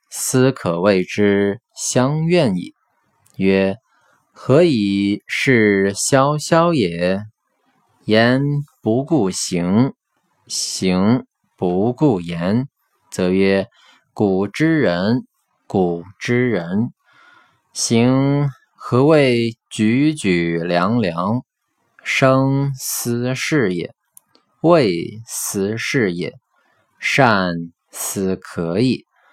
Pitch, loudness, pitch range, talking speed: 110 Hz, -18 LUFS, 95-135 Hz, 100 characters per minute